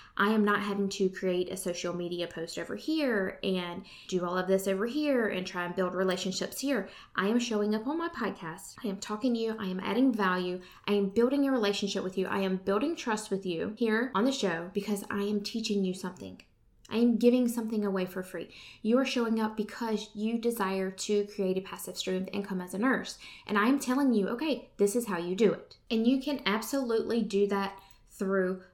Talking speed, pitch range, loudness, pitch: 225 wpm, 190-230 Hz, -30 LUFS, 205 Hz